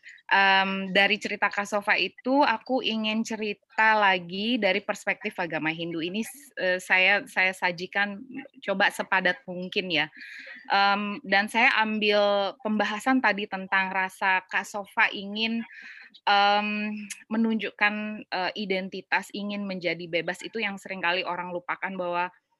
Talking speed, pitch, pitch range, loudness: 125 wpm, 200 Hz, 185-215 Hz, -25 LUFS